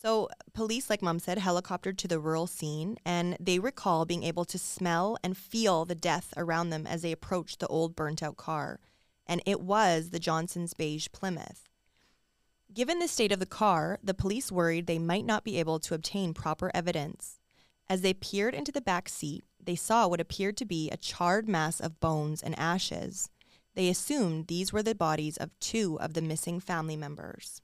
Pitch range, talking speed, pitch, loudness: 165-200 Hz, 195 wpm, 175 Hz, -31 LUFS